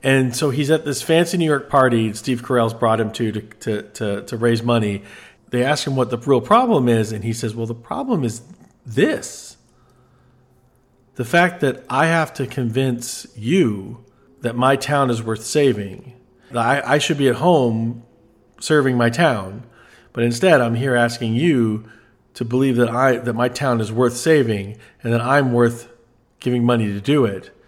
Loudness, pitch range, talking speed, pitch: -19 LUFS, 115-135 Hz, 185 wpm, 125 Hz